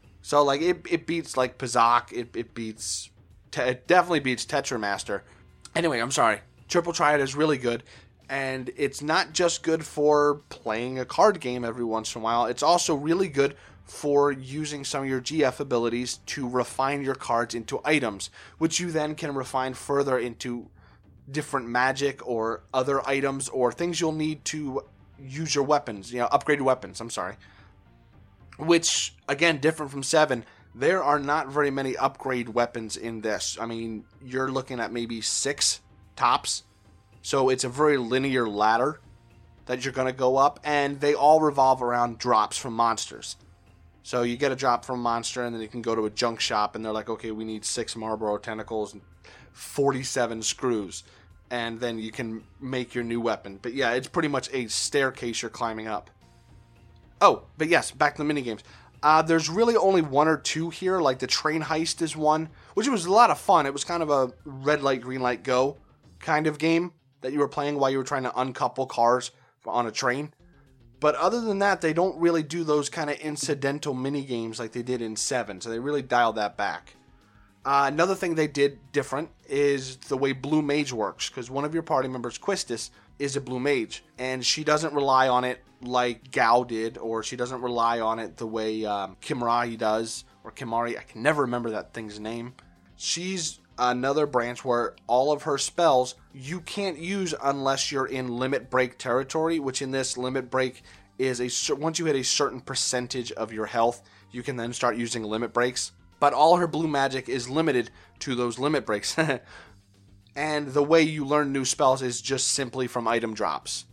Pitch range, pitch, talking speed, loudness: 115-145 Hz, 130 Hz, 190 wpm, -26 LUFS